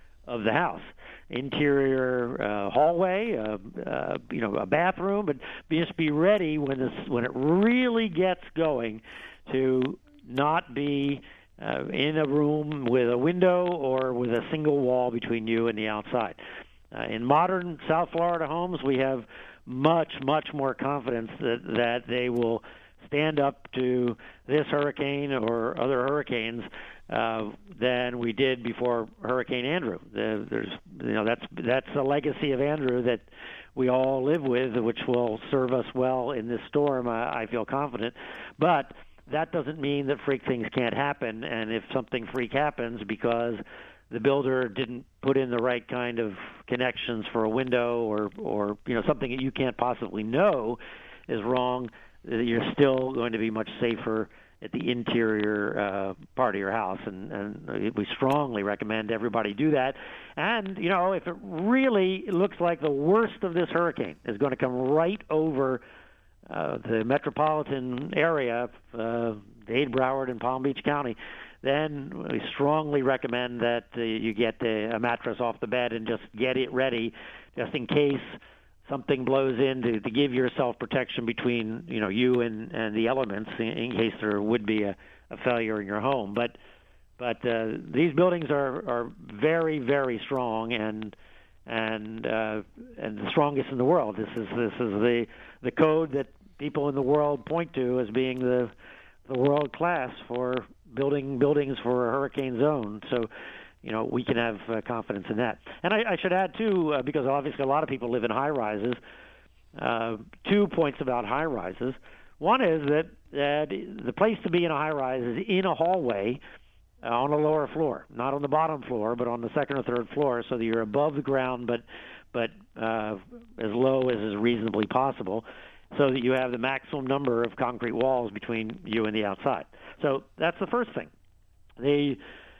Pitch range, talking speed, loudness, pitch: 115-145 Hz, 175 wpm, -28 LUFS, 130 Hz